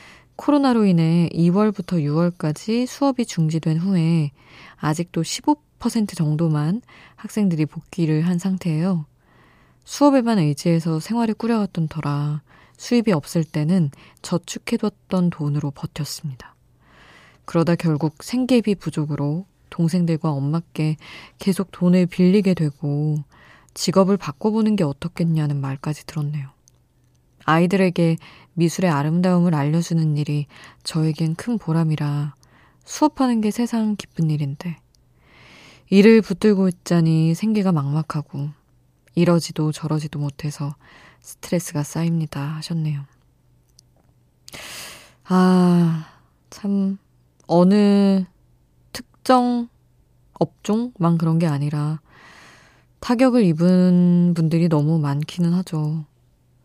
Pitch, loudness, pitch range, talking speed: 165 Hz, -20 LUFS, 150-190 Hz, 245 characters per minute